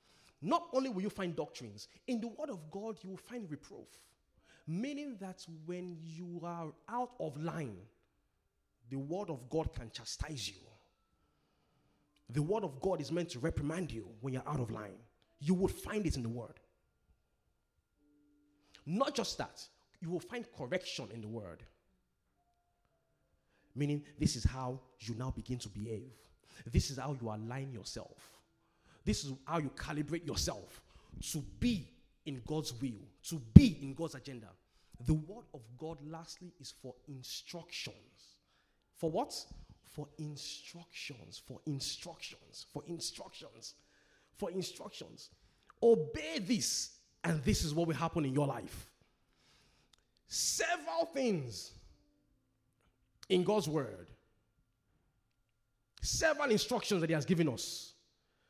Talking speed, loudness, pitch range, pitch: 135 wpm, -37 LUFS, 115-170 Hz, 145 Hz